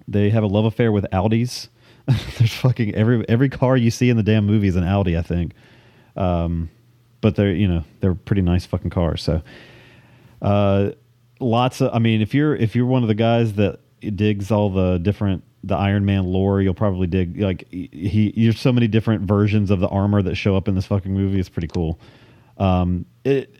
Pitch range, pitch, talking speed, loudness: 95-115 Hz, 105 Hz, 210 wpm, -20 LUFS